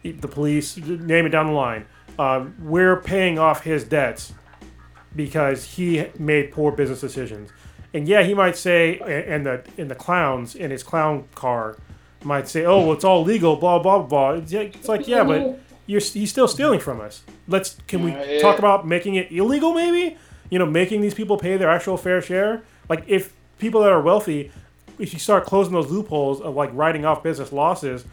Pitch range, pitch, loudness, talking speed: 145-195 Hz, 165 Hz, -20 LUFS, 195 wpm